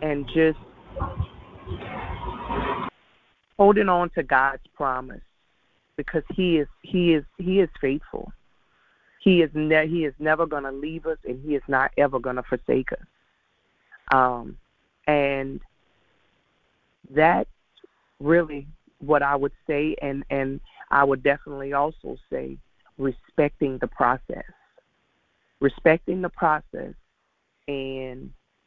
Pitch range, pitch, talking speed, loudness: 135-160 Hz, 145 Hz, 115 wpm, -24 LUFS